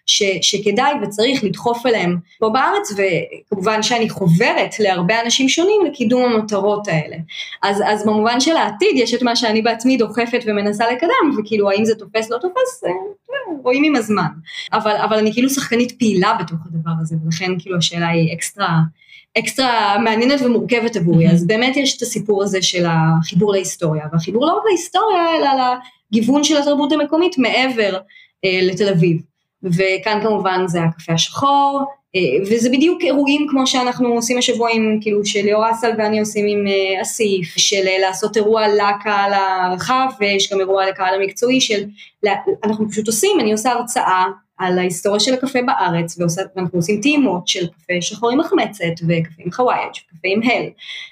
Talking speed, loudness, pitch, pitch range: 160 wpm, -16 LUFS, 215 Hz, 190-250 Hz